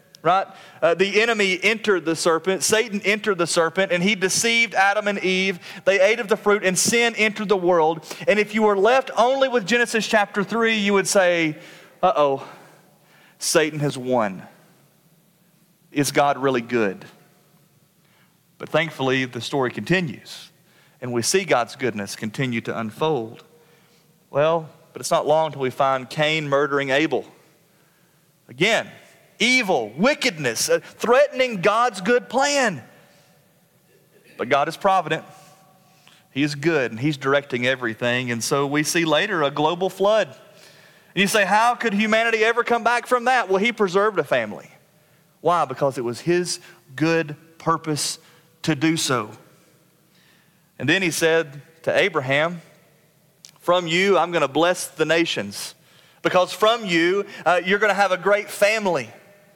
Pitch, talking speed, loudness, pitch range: 175 Hz, 150 wpm, -20 LUFS, 155-200 Hz